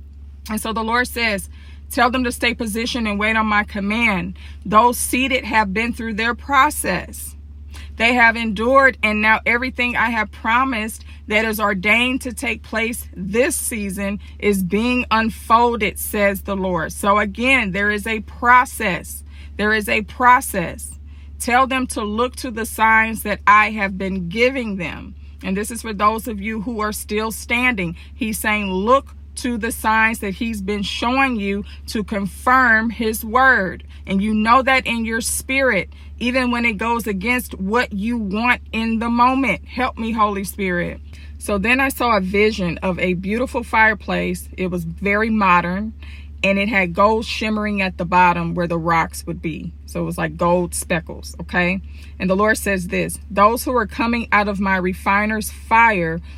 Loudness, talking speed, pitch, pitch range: -18 LUFS, 175 wpm, 215 Hz, 185-235 Hz